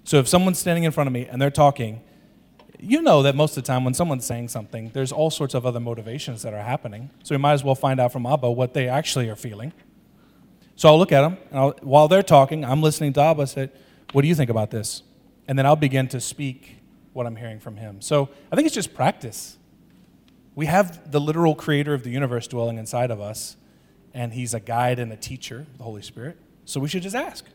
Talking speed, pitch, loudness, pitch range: 240 wpm, 135 Hz, -21 LUFS, 120-155 Hz